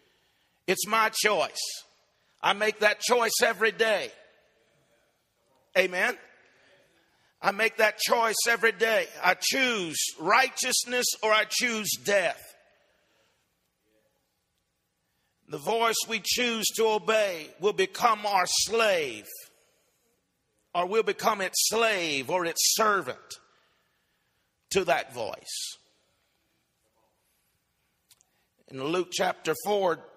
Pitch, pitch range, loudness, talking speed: 225 Hz, 195-245 Hz, -26 LUFS, 95 wpm